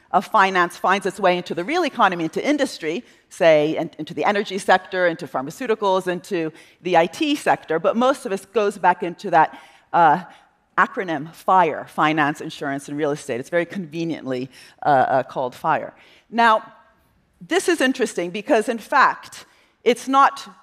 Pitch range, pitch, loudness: 165-225 Hz, 185 Hz, -20 LUFS